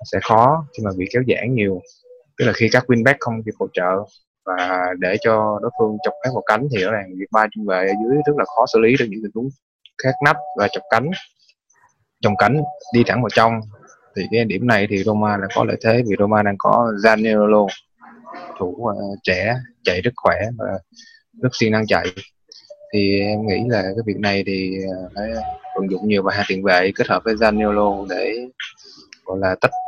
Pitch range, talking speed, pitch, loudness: 100-125 Hz, 210 wpm, 110 Hz, -19 LUFS